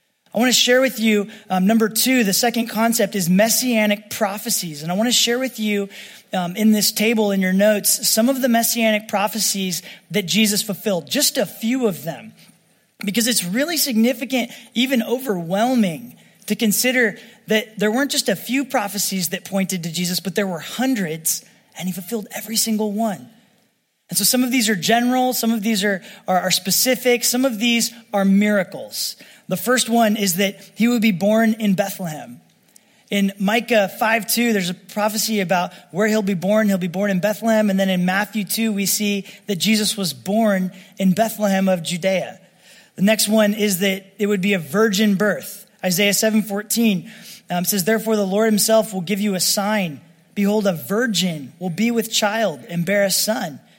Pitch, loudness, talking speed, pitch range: 210 Hz, -19 LUFS, 190 wpm, 195-225 Hz